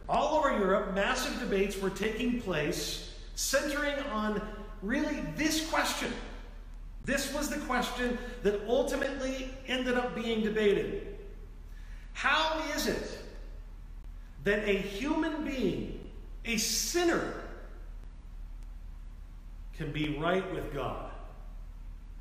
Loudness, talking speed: -32 LUFS, 100 wpm